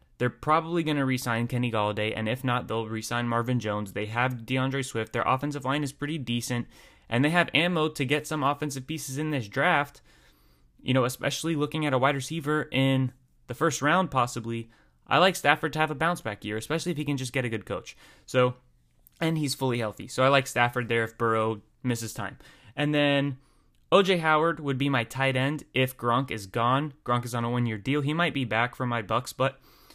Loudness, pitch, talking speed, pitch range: -27 LUFS, 130 Hz, 220 wpm, 115-145 Hz